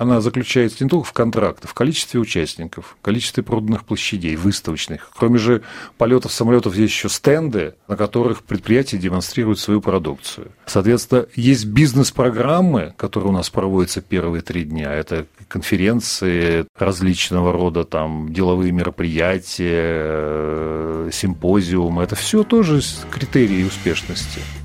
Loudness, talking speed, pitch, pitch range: -18 LUFS, 120 wpm, 100 Hz, 85-120 Hz